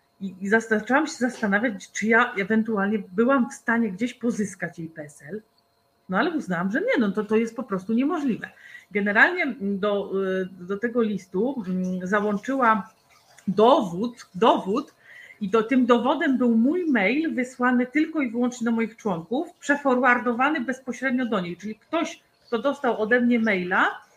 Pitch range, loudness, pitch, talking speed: 205-260 Hz, -23 LUFS, 230 Hz, 145 wpm